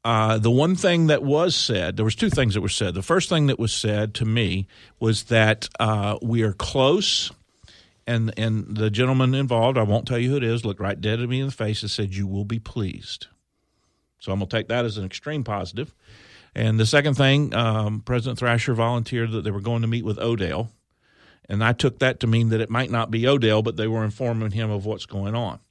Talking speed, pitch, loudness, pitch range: 235 wpm, 115 Hz, -22 LUFS, 105-120 Hz